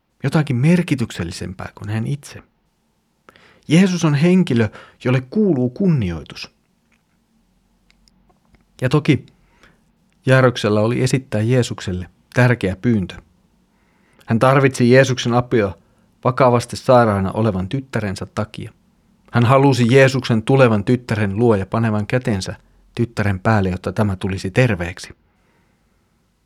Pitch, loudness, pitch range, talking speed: 120 Hz, -17 LUFS, 105-135 Hz, 100 wpm